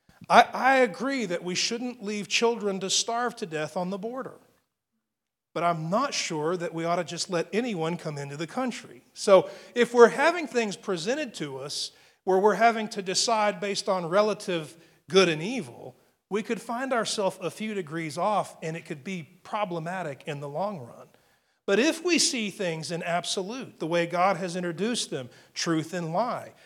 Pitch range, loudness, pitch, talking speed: 170-225 Hz, -27 LUFS, 190 Hz, 180 wpm